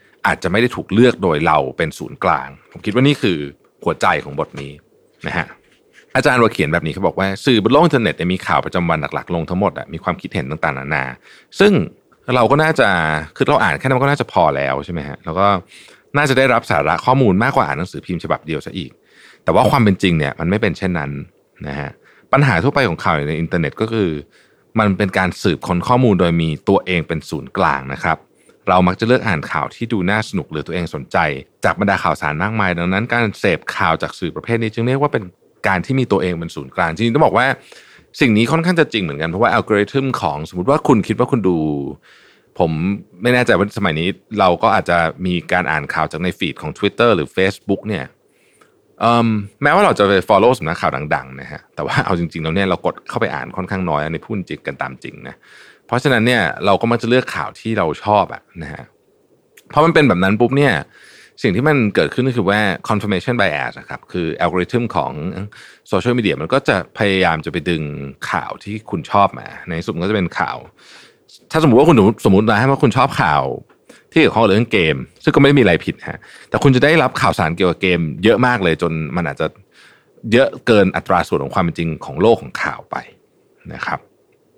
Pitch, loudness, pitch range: 95 Hz, -16 LUFS, 85-115 Hz